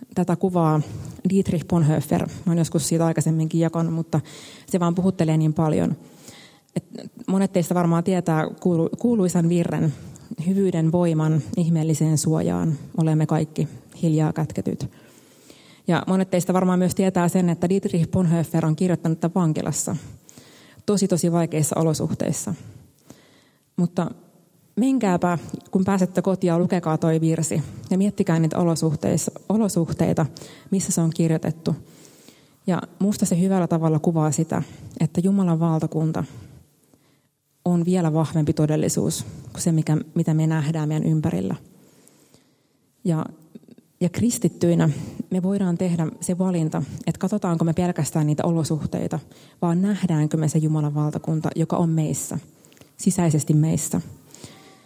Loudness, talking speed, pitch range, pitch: -22 LUFS, 120 wpm, 155-180 Hz, 165 Hz